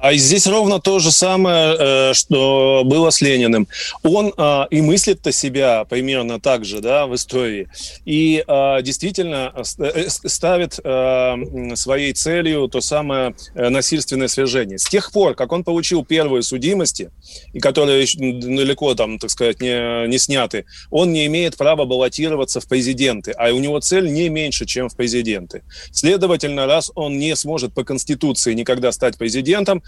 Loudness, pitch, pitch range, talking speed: -16 LUFS, 135 Hz, 125-160 Hz, 145 wpm